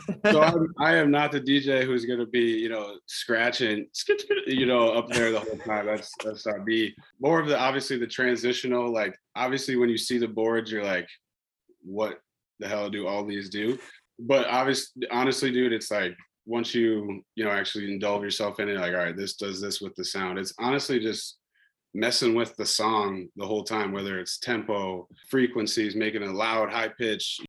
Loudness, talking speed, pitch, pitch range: -26 LUFS, 195 wpm, 115 Hz, 105-130 Hz